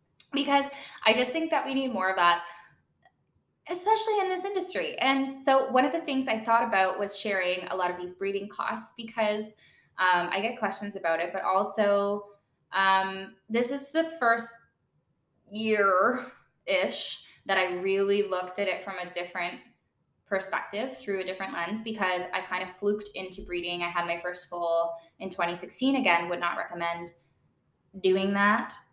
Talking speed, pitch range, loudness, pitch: 170 wpm, 180-230 Hz, -28 LUFS, 195 Hz